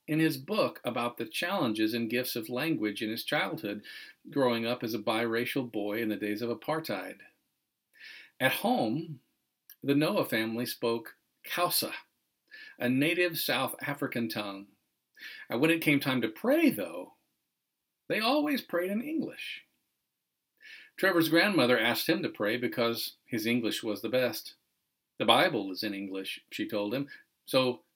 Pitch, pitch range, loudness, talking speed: 125 Hz, 115-165 Hz, -30 LUFS, 150 wpm